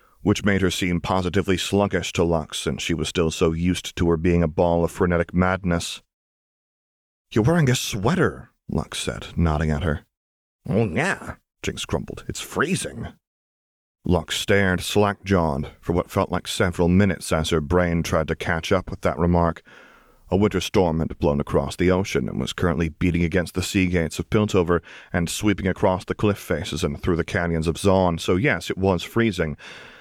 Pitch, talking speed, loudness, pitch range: 90 Hz, 185 wpm, -22 LUFS, 85-95 Hz